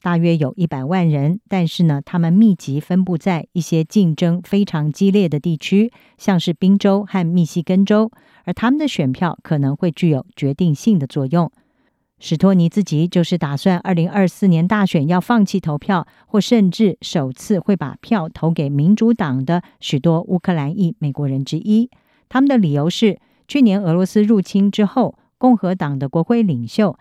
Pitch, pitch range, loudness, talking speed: 180 Hz, 160-200 Hz, -17 LUFS, 275 characters per minute